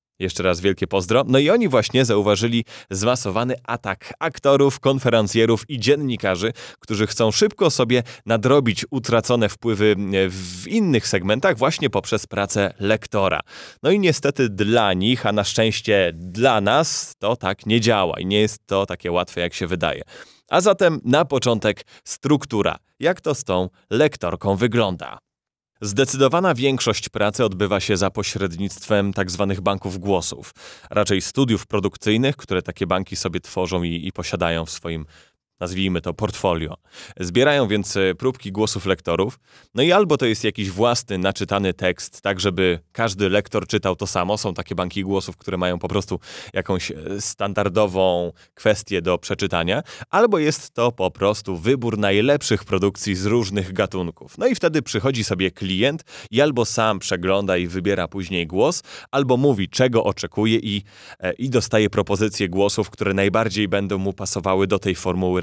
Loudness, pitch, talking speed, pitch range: -20 LUFS, 100 Hz, 150 wpm, 95-115 Hz